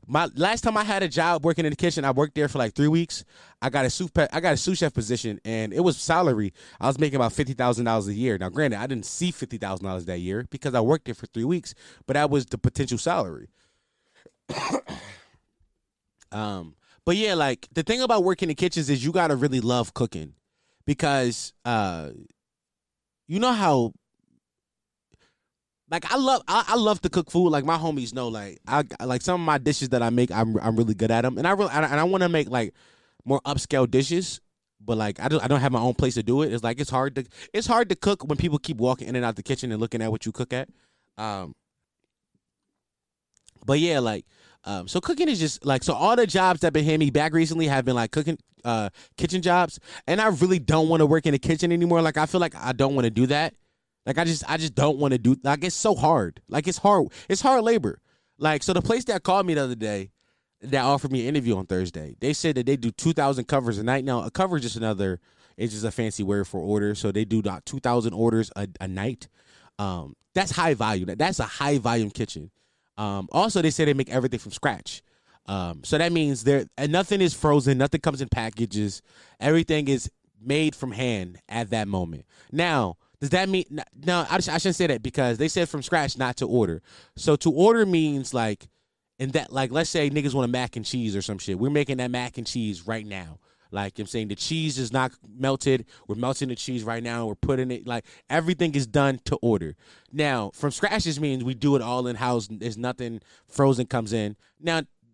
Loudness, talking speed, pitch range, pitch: -25 LUFS, 230 wpm, 115-160 Hz, 135 Hz